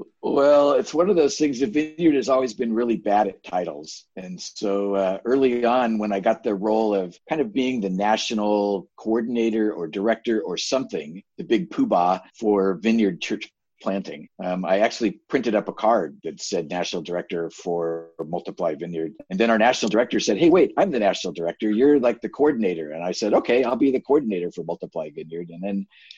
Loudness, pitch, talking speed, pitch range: -22 LUFS, 105 Hz, 195 wpm, 95-120 Hz